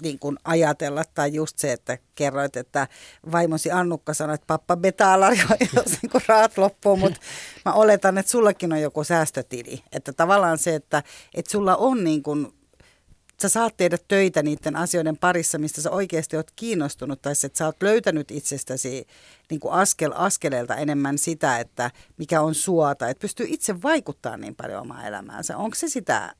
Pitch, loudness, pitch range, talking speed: 165 Hz, -22 LUFS, 150-195 Hz, 175 wpm